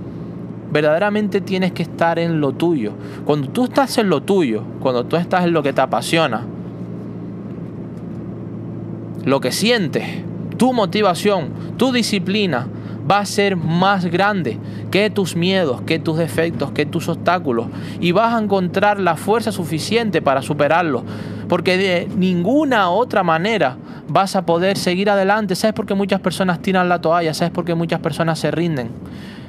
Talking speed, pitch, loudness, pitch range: 155 wpm, 175 Hz, -18 LUFS, 160-200 Hz